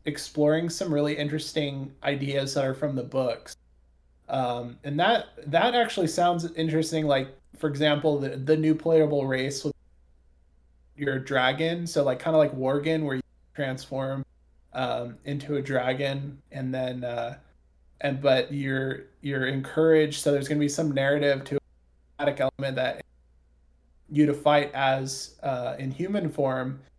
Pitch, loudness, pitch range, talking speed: 140 Hz, -27 LUFS, 130-150 Hz, 150 wpm